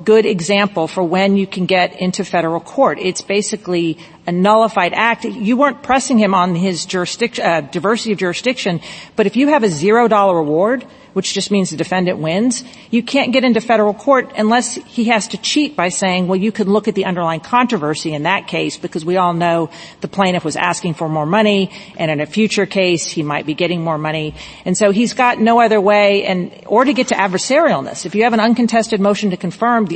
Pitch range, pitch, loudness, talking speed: 175-225 Hz, 200 Hz, -15 LUFS, 210 wpm